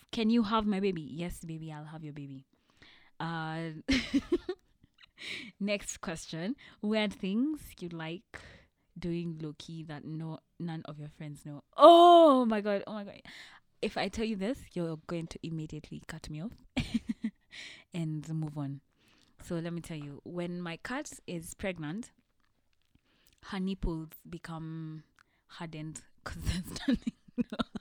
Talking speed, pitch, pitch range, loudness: 140 wpm, 170 Hz, 155-215 Hz, -31 LUFS